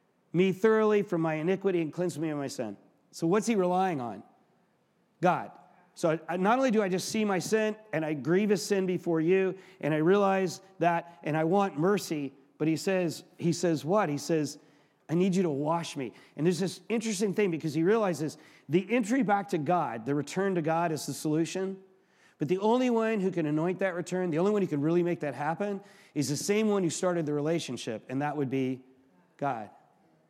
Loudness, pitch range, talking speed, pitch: -29 LUFS, 155-195 Hz, 215 wpm, 175 Hz